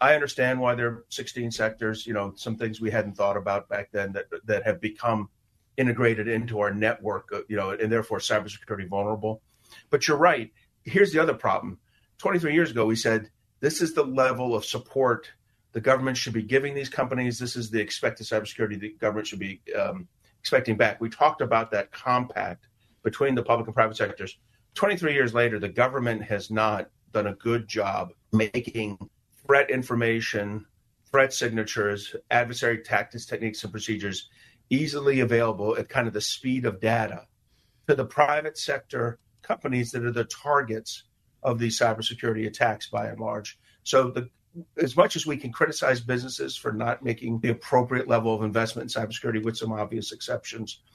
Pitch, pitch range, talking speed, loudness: 115 Hz, 110-125 Hz, 175 wpm, -26 LUFS